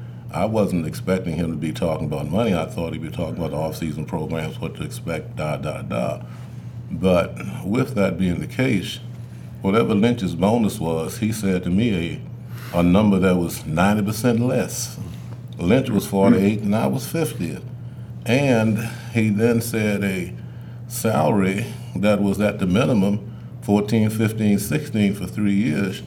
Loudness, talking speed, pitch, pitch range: -21 LUFS, 160 wpm, 105 Hz, 90-115 Hz